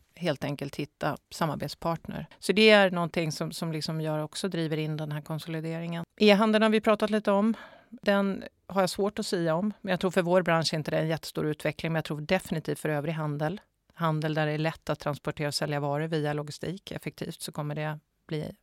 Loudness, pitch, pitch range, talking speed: -28 LUFS, 165 Hz, 155-195 Hz, 220 wpm